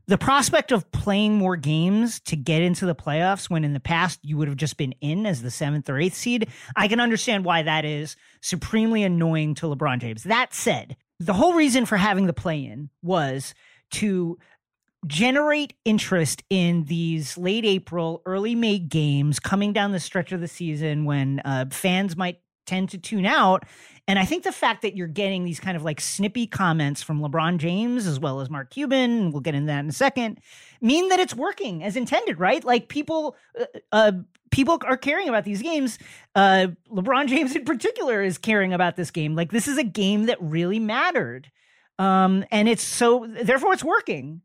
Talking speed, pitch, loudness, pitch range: 195 wpm, 190 Hz, -23 LUFS, 160-230 Hz